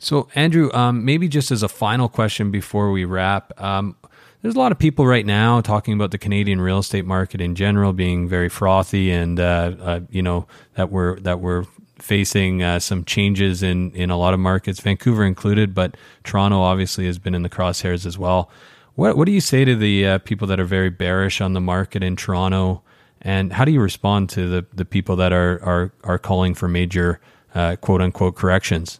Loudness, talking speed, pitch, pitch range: -19 LUFS, 205 wpm, 95 Hz, 90-105 Hz